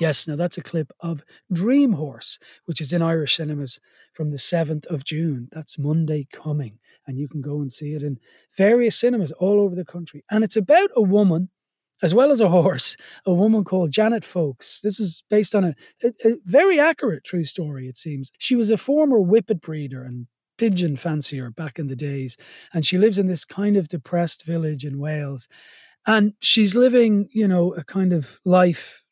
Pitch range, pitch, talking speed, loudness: 150-210 Hz, 175 Hz, 200 wpm, -21 LUFS